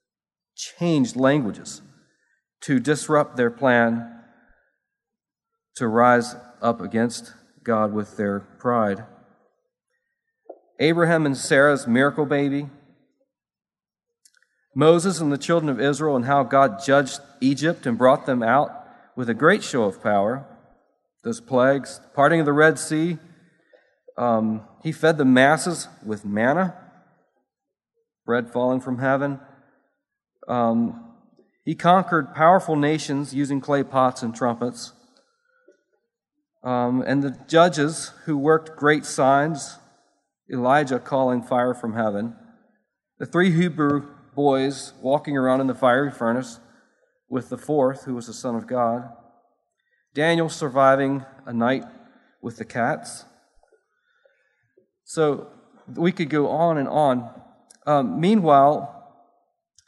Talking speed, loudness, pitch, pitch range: 115 wpm, -21 LUFS, 140 Hz, 125-165 Hz